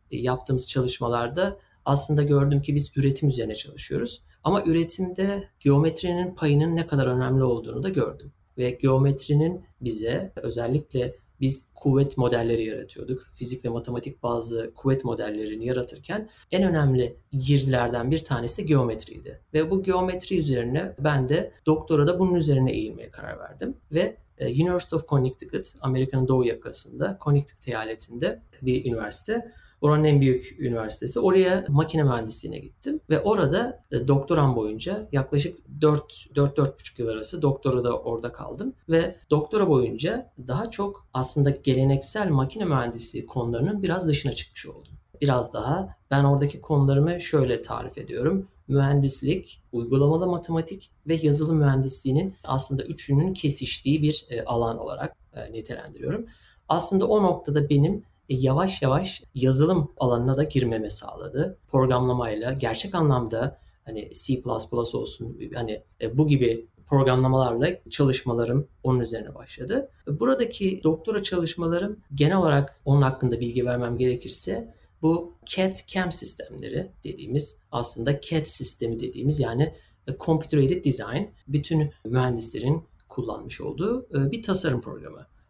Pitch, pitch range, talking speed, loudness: 140 Hz, 125-160 Hz, 120 wpm, -25 LUFS